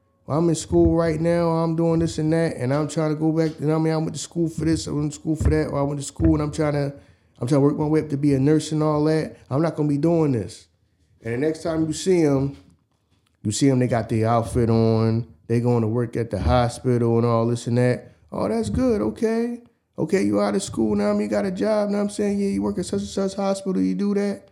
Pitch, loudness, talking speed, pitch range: 150 Hz, -22 LUFS, 290 wpm, 115-165 Hz